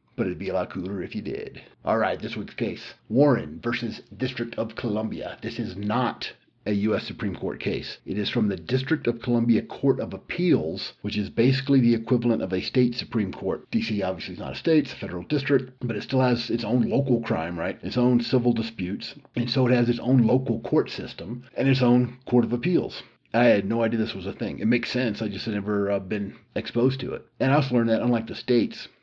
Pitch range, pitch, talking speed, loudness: 110-125 Hz, 120 Hz, 235 wpm, -25 LUFS